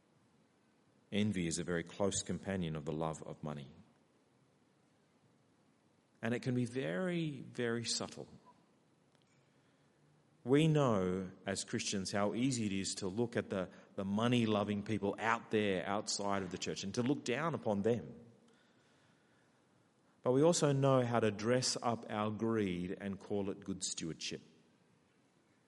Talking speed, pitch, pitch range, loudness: 145 wpm, 105 Hz, 95-120 Hz, -36 LUFS